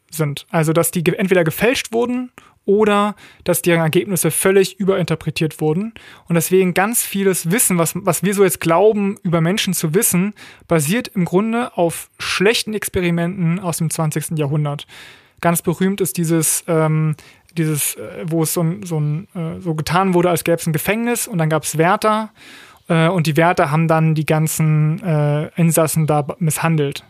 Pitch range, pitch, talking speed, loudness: 160-195 Hz, 170 Hz, 170 wpm, -17 LUFS